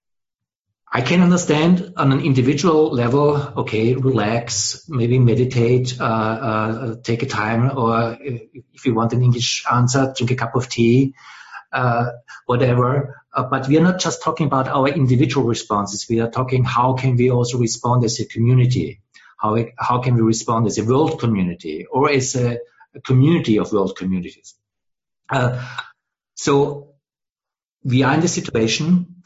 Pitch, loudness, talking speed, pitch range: 125 Hz, -18 LUFS, 155 wpm, 115-140 Hz